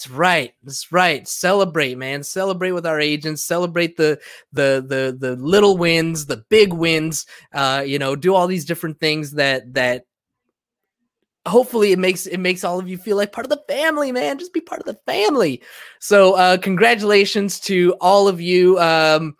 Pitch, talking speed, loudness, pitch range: 180 Hz, 185 wpm, -17 LUFS, 150-195 Hz